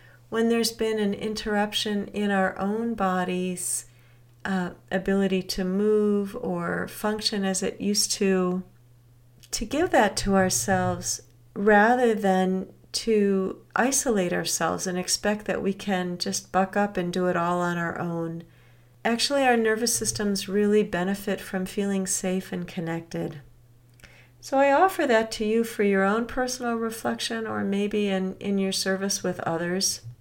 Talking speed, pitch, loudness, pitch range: 145 wpm, 195 Hz, -25 LUFS, 175-215 Hz